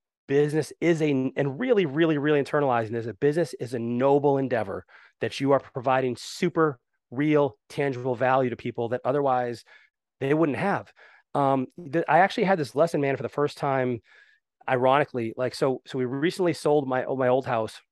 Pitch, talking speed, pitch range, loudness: 135 Hz, 175 wpm, 125-150 Hz, -25 LUFS